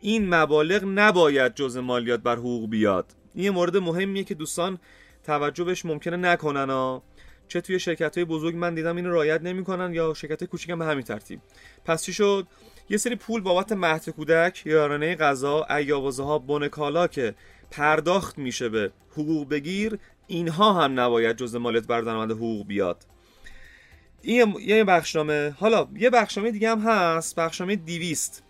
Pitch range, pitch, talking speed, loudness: 140-185 Hz, 165 Hz, 160 wpm, -24 LUFS